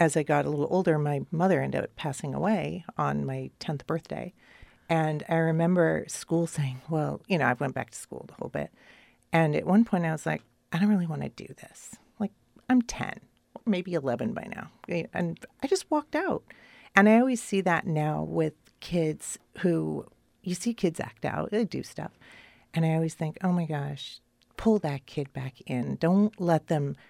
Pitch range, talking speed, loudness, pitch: 150-195 Hz, 200 wpm, -28 LUFS, 165 Hz